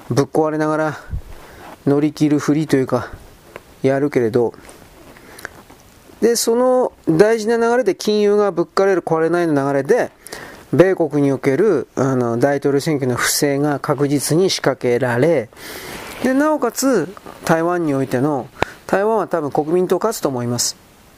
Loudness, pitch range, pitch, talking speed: -17 LUFS, 140-190 Hz, 155 Hz, 280 characters per minute